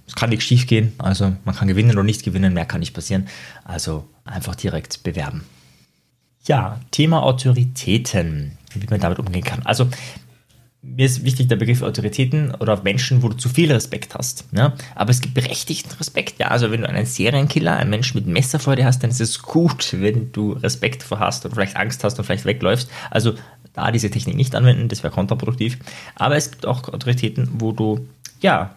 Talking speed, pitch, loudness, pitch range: 195 wpm, 120 Hz, -19 LUFS, 105-130 Hz